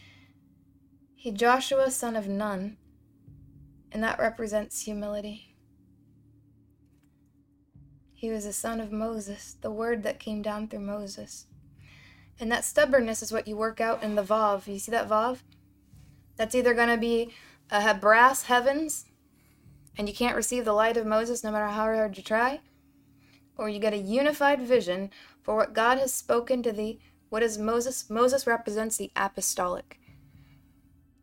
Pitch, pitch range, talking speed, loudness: 215 Hz, 180-235 Hz, 150 wpm, -27 LUFS